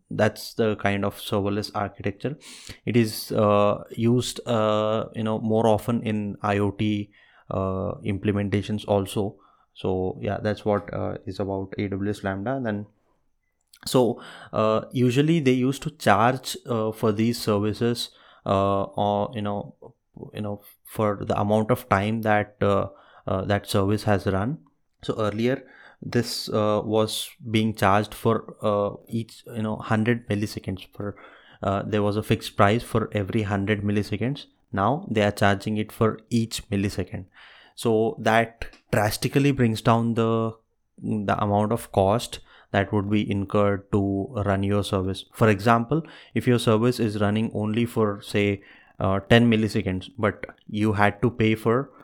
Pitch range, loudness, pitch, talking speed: 100-115 Hz, -24 LUFS, 105 Hz, 150 wpm